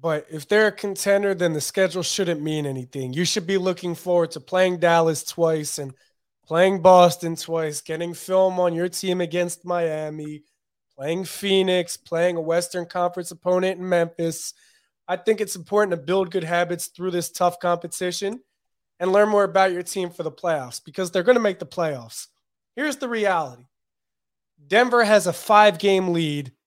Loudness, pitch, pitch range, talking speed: -22 LUFS, 175 Hz, 165-190 Hz, 175 wpm